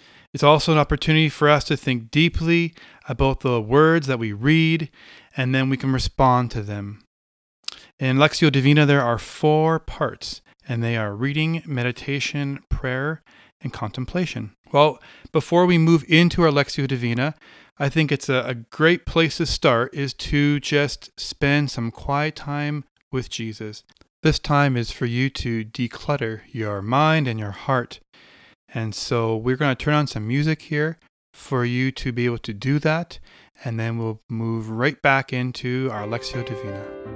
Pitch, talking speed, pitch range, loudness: 135 Hz, 165 wpm, 120-150 Hz, -21 LUFS